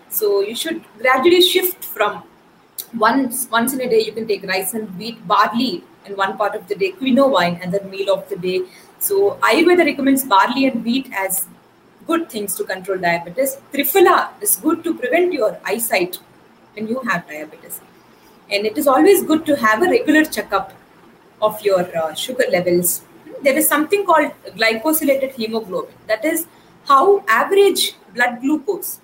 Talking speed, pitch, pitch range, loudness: 170 wpm, 250 Hz, 200-320 Hz, -17 LUFS